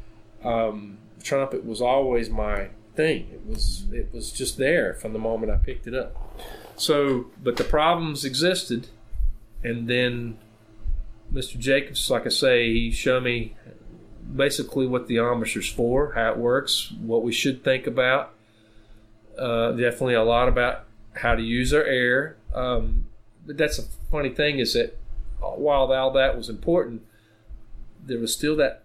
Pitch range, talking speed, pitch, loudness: 110-130 Hz, 155 wpm, 120 Hz, -24 LUFS